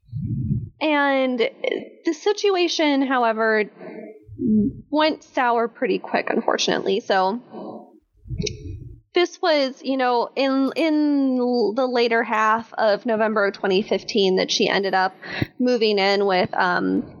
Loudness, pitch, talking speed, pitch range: -21 LUFS, 245 Hz, 110 wpm, 210-285 Hz